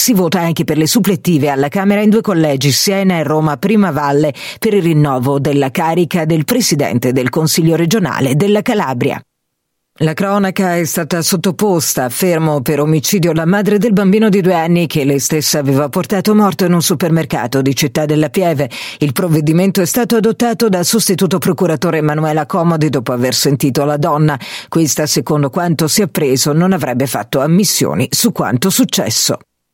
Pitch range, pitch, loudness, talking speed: 145-190 Hz, 165 Hz, -13 LUFS, 170 wpm